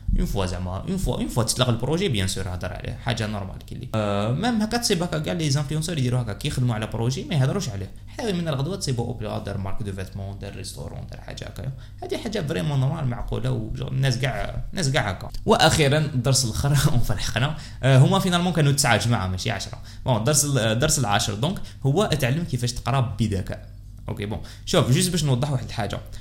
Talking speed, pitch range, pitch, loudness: 200 wpm, 105-140 Hz, 120 Hz, -23 LUFS